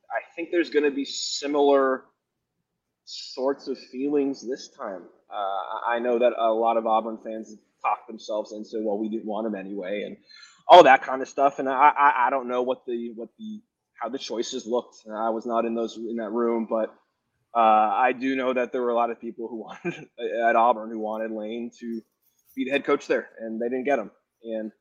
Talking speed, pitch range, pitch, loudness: 220 wpm, 110-135 Hz, 120 Hz, -24 LUFS